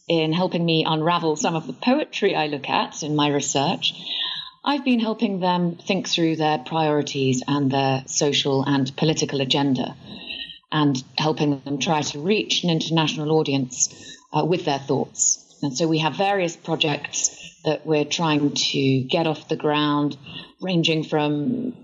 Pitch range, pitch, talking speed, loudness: 145-170 Hz, 155 Hz, 155 wpm, -22 LUFS